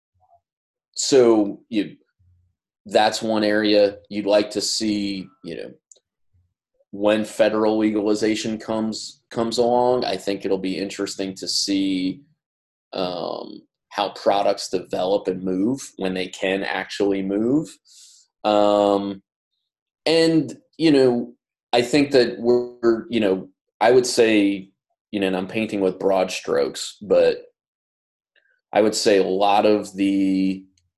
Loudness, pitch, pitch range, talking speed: -21 LUFS, 105 Hz, 95-120 Hz, 125 wpm